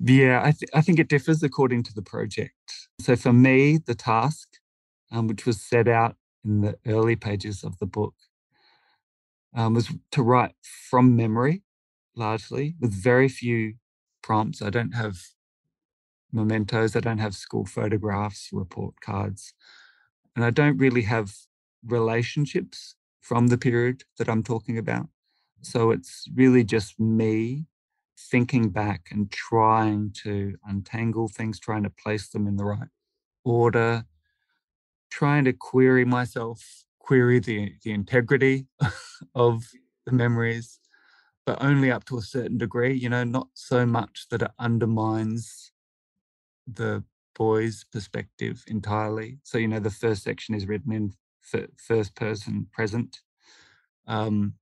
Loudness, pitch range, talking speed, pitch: -25 LUFS, 110-125 Hz, 140 wpm, 115 Hz